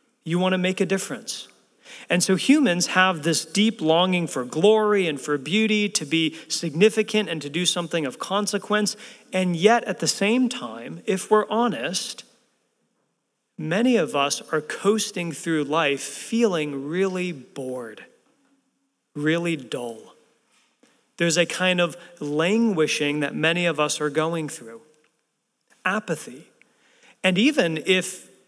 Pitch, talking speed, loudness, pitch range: 185 Hz, 135 wpm, -23 LUFS, 155-220 Hz